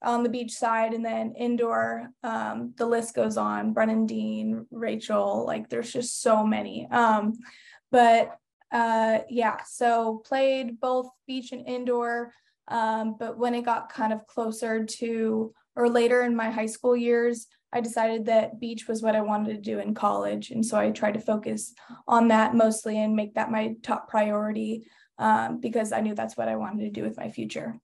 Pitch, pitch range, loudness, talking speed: 225 Hz, 220-235 Hz, -26 LUFS, 185 wpm